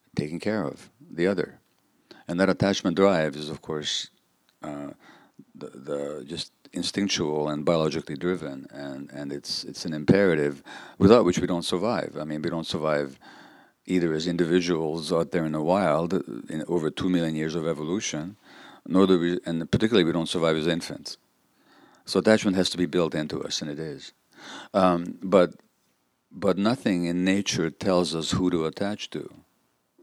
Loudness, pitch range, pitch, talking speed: -25 LUFS, 75-90 Hz, 85 Hz, 170 wpm